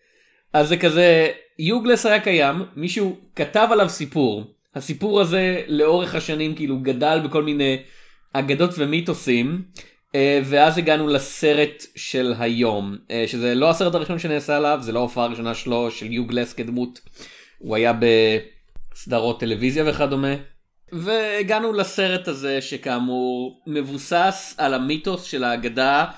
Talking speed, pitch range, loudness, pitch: 120 wpm, 125-175 Hz, -21 LUFS, 145 Hz